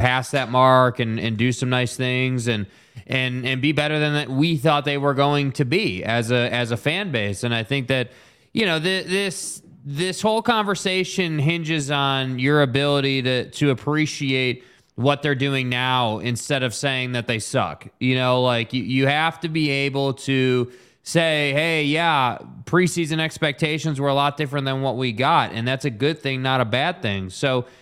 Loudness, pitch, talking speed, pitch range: -21 LUFS, 135 Hz, 190 wpm, 125-150 Hz